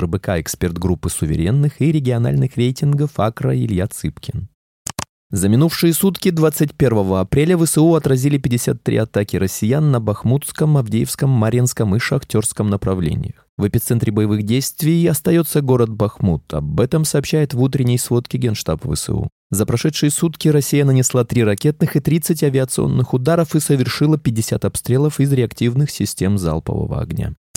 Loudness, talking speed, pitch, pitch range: -17 LUFS, 135 wpm, 130 Hz, 110-150 Hz